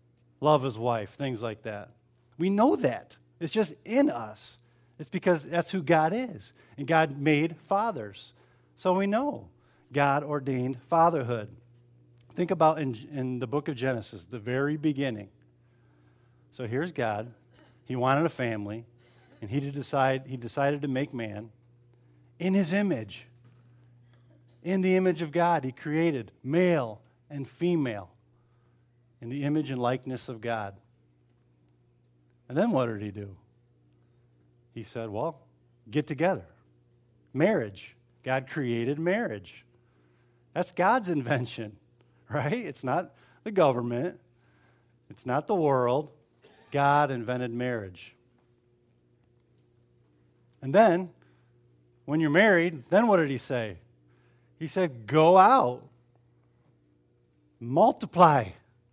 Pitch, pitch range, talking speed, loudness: 120 Hz, 110-150 Hz, 125 wpm, -27 LUFS